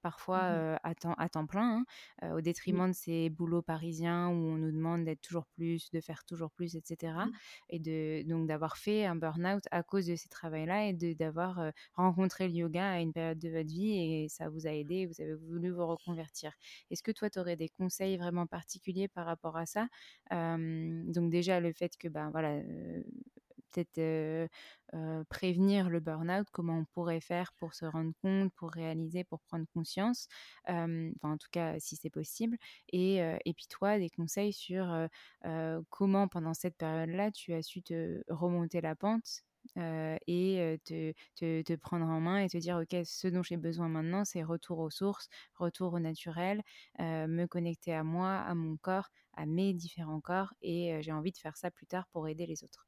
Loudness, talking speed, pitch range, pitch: -37 LUFS, 205 wpm, 160-185 Hz, 170 Hz